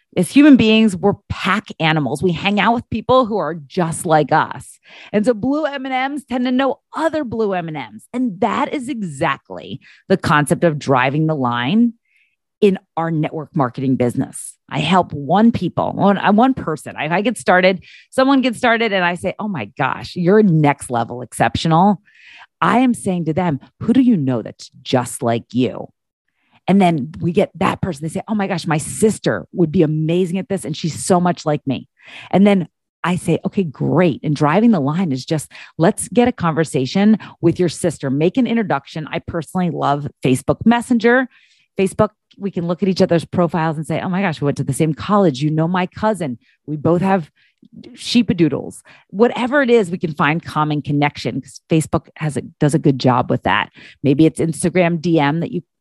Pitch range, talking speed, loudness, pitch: 150-210 Hz, 200 wpm, -17 LUFS, 175 Hz